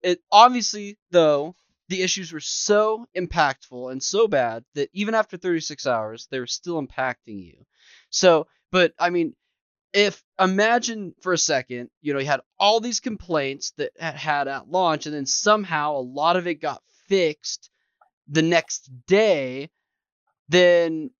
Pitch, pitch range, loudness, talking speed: 170 Hz, 140-195 Hz, -22 LUFS, 155 wpm